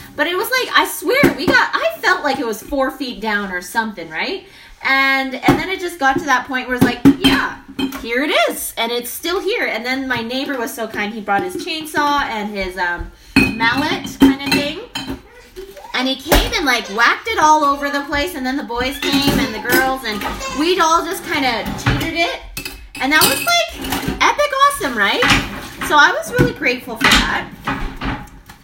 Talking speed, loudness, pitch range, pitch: 205 wpm, -16 LUFS, 245-320 Hz, 275 Hz